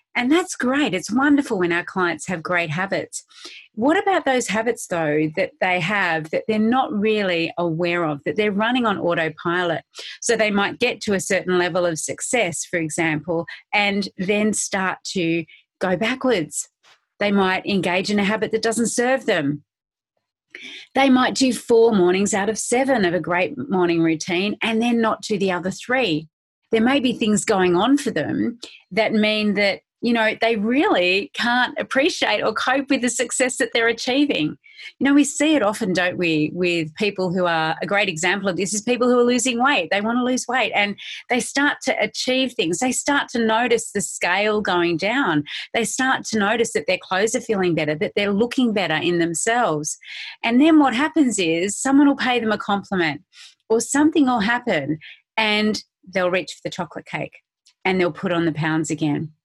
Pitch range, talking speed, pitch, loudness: 180-245 Hz, 190 wpm, 210 Hz, -20 LUFS